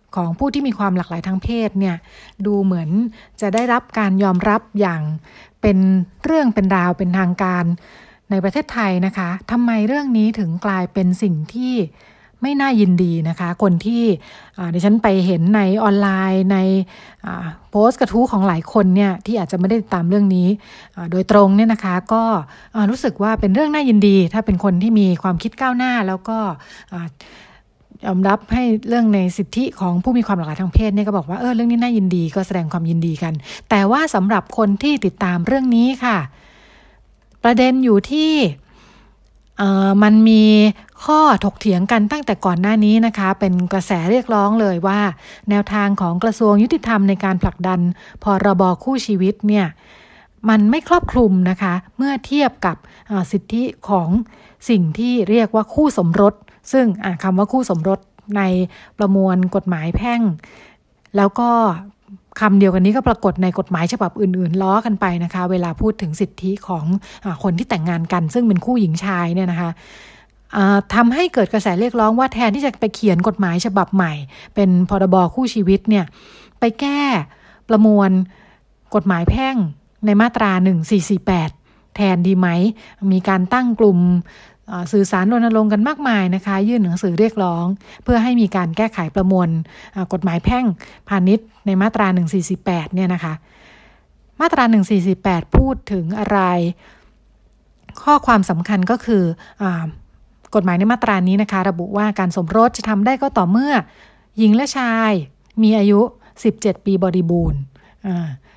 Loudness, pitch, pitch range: -17 LUFS, 200 Hz, 185-225 Hz